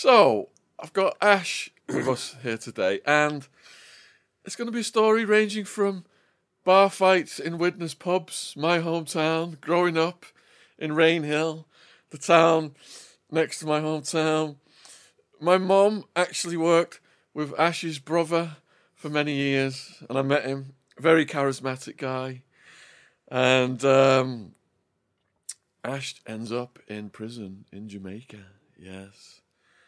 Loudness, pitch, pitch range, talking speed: -24 LUFS, 155 Hz, 130-175 Hz, 120 wpm